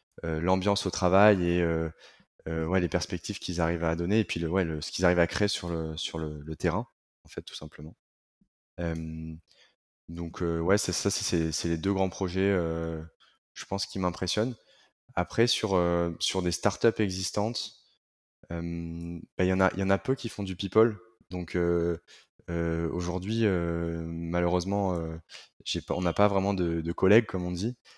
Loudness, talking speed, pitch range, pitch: -29 LUFS, 190 wpm, 85-95 Hz, 90 Hz